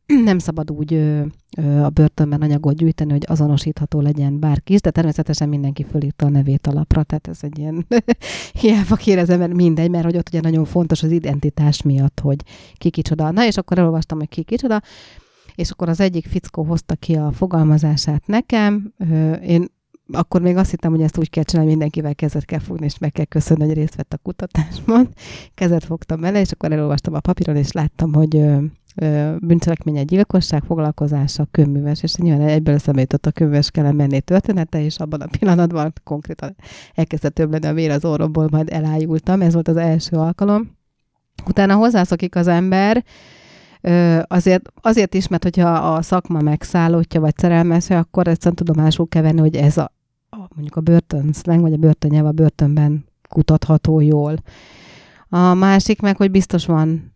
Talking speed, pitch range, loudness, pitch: 175 wpm, 150-175 Hz, -17 LUFS, 160 Hz